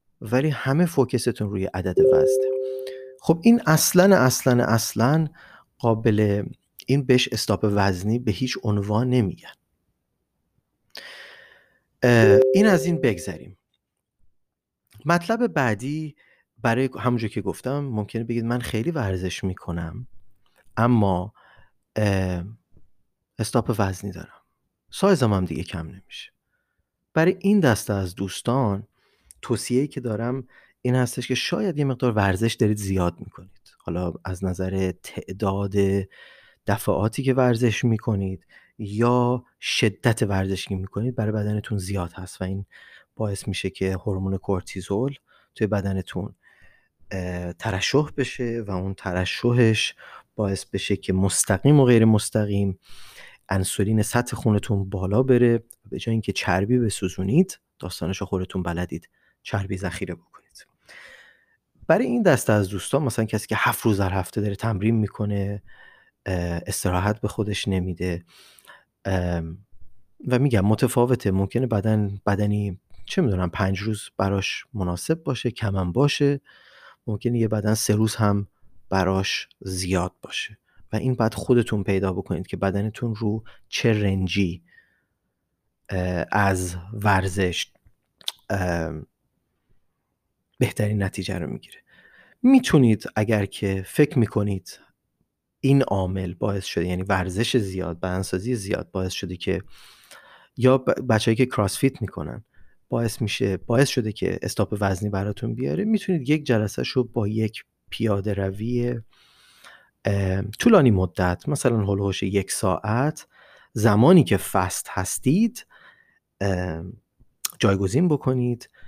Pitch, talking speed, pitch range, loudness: 105 Hz, 115 wpm, 95-125 Hz, -23 LUFS